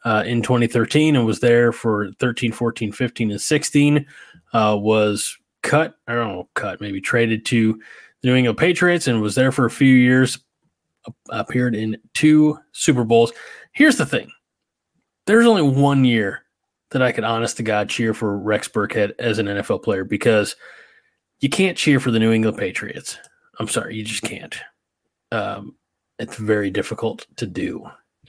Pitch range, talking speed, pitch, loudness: 110-135 Hz, 170 wpm, 120 Hz, -19 LUFS